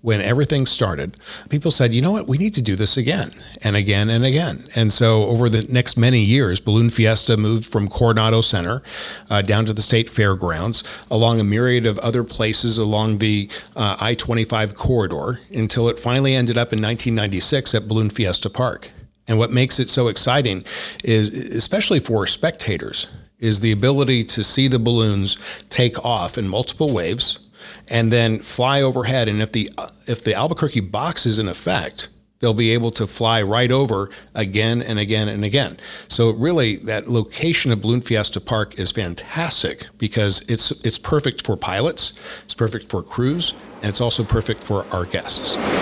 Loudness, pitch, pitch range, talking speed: -18 LUFS, 115 Hz, 110-125 Hz, 175 wpm